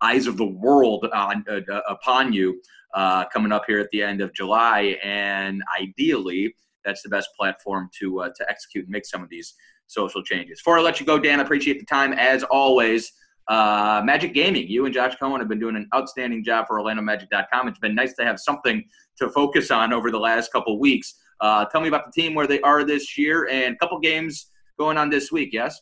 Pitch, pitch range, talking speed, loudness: 125 Hz, 105-150 Hz, 225 wpm, -21 LUFS